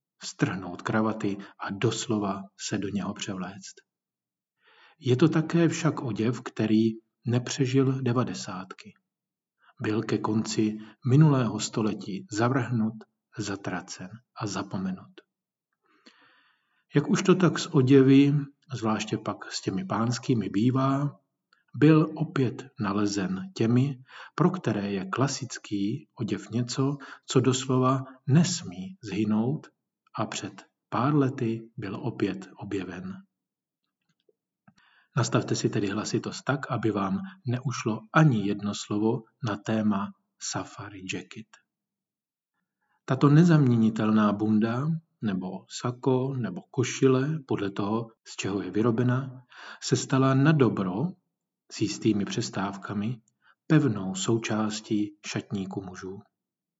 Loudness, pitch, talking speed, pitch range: -27 LUFS, 115 Hz, 100 wpm, 105-135 Hz